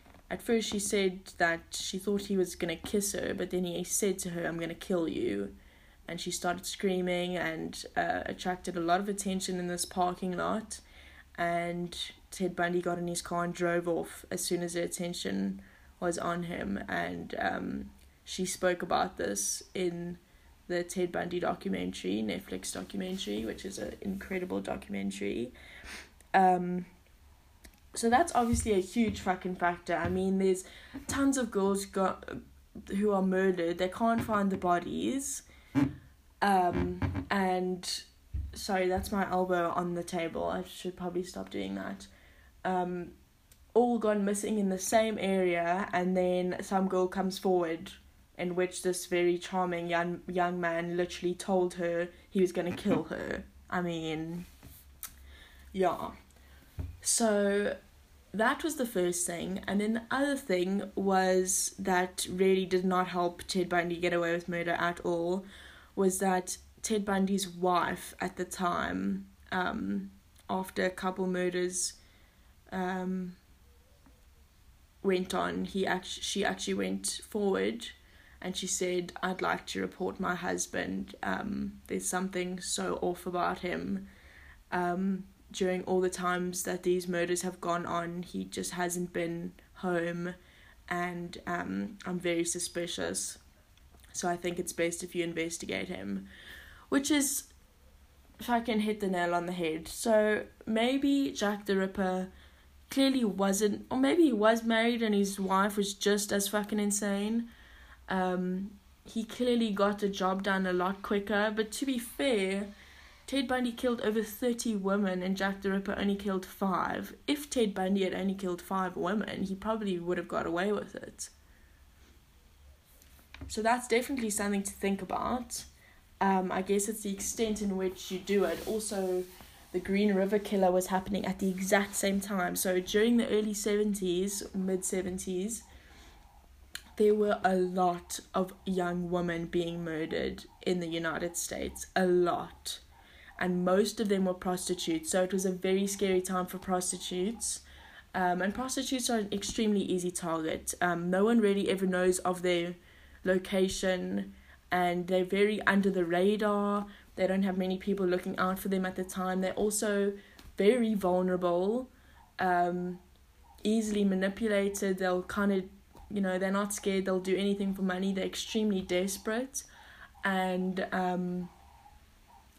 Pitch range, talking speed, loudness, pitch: 175-200 Hz, 155 wpm, -32 LUFS, 185 Hz